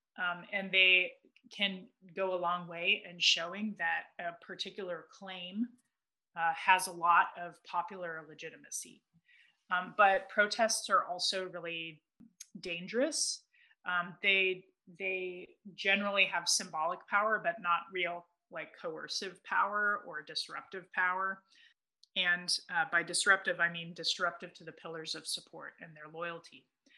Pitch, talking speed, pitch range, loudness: 185 Hz, 130 wpm, 170-200 Hz, -32 LUFS